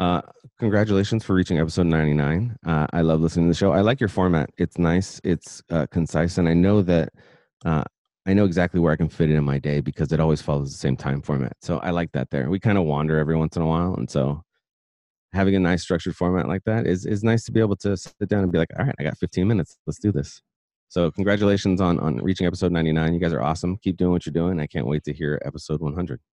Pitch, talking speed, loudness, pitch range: 85 Hz, 260 wpm, -22 LUFS, 80-95 Hz